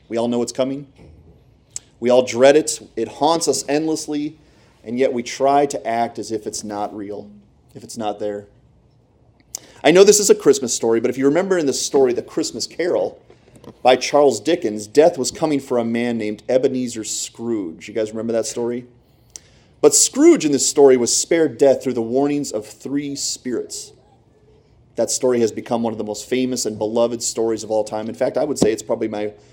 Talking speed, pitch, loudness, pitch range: 200 wpm, 125 Hz, -18 LUFS, 110-145 Hz